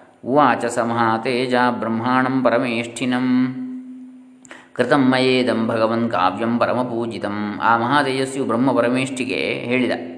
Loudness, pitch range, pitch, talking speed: -19 LUFS, 115-130 Hz, 125 Hz, 70 wpm